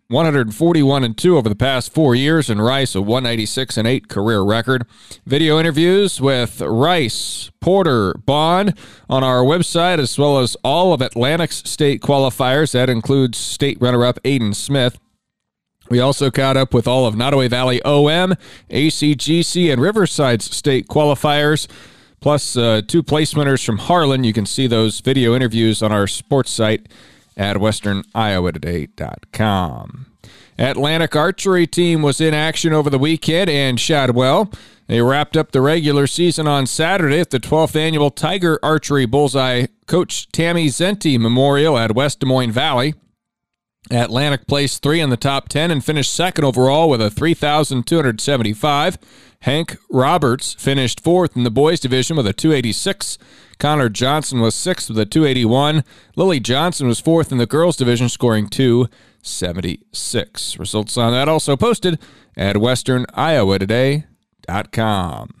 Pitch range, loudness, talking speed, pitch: 120-155 Hz, -16 LUFS, 145 wpm, 135 Hz